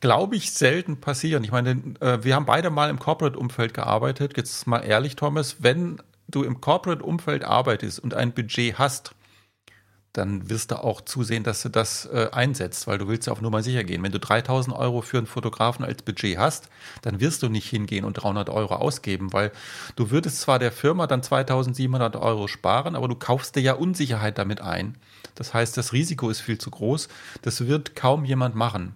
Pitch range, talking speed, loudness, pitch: 110-140 Hz, 195 wpm, -24 LUFS, 125 Hz